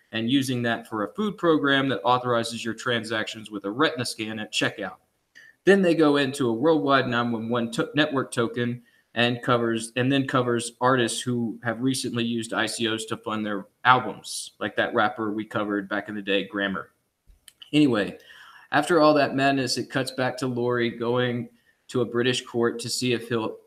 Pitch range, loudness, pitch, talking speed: 115-130 Hz, -24 LUFS, 120 Hz, 180 wpm